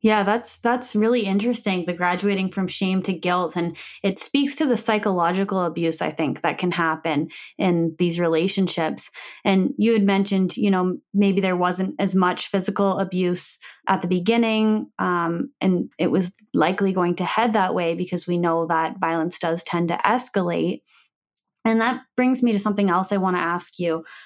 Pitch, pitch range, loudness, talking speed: 190 Hz, 175-210 Hz, -22 LUFS, 180 wpm